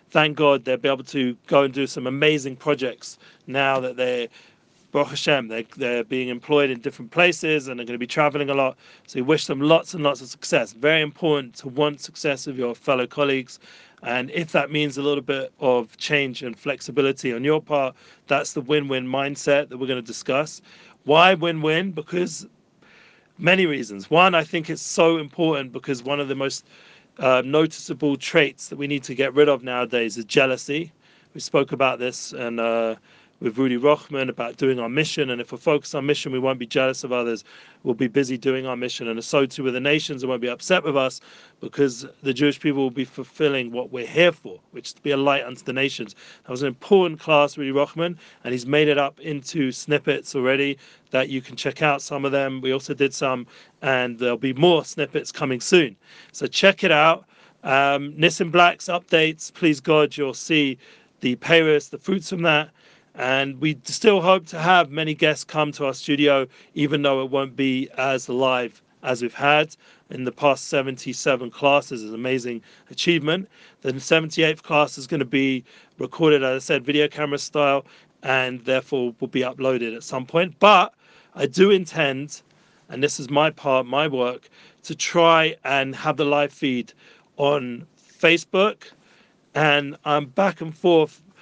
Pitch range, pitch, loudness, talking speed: 130-155 Hz, 140 Hz, -21 LUFS, 195 wpm